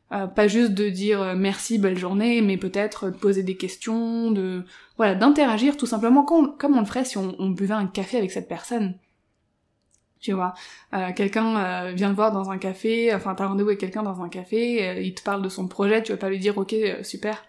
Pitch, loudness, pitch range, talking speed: 200 Hz, -23 LUFS, 190-225 Hz, 230 wpm